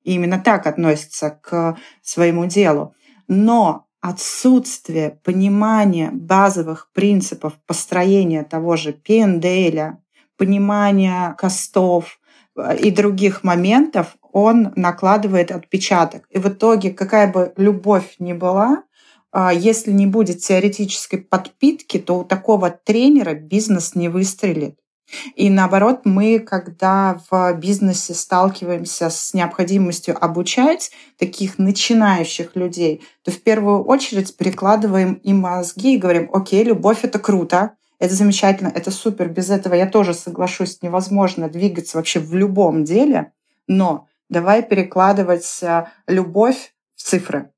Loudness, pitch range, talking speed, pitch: -17 LUFS, 175-205 Hz, 115 wpm, 190 Hz